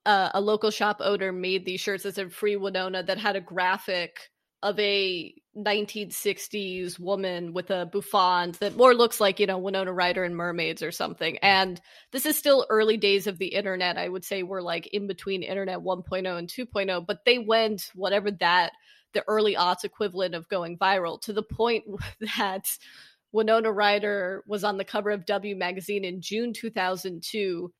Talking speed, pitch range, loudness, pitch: 180 wpm, 185-210 Hz, -26 LUFS, 195 Hz